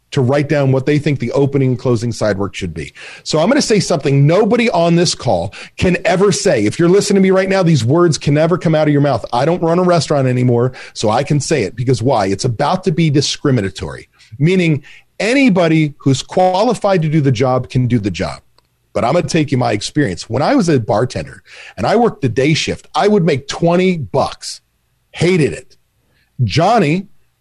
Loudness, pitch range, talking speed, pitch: -14 LUFS, 130-175 Hz, 220 wpm, 150 Hz